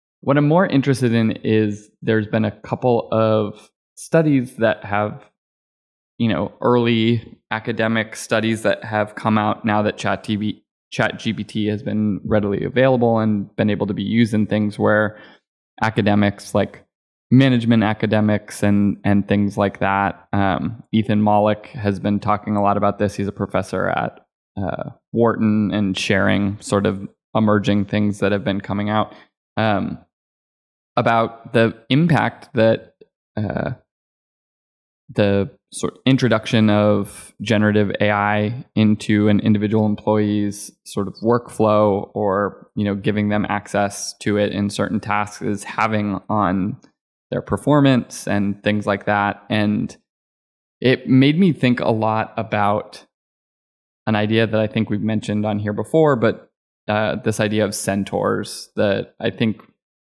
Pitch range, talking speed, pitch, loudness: 100-110 Hz, 145 wpm, 105 Hz, -19 LUFS